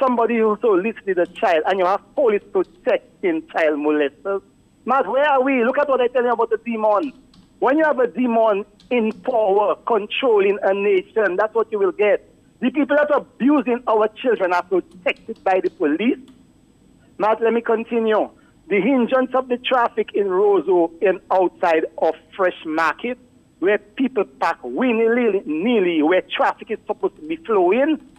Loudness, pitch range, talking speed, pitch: -19 LUFS, 200-275 Hz, 170 wpm, 230 Hz